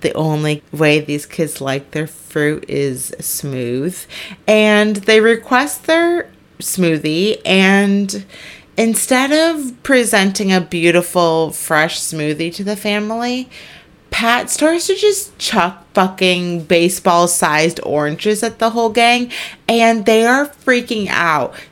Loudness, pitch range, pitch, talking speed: -15 LUFS, 160-230 Hz, 195 Hz, 120 wpm